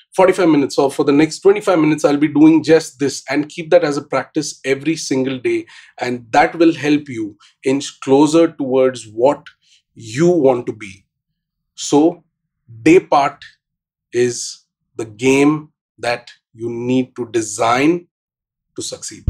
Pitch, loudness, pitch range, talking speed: 150 Hz, -16 LUFS, 130-170 Hz, 150 wpm